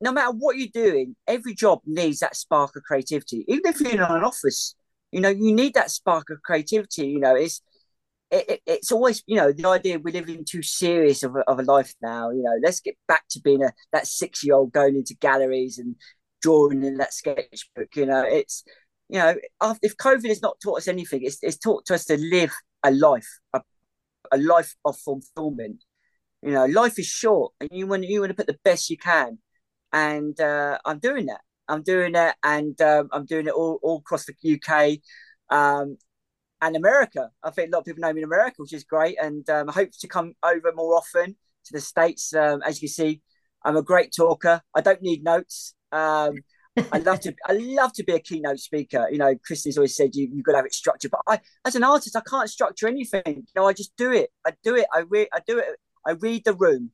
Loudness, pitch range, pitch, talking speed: -22 LUFS, 150-220 Hz, 165 Hz, 230 wpm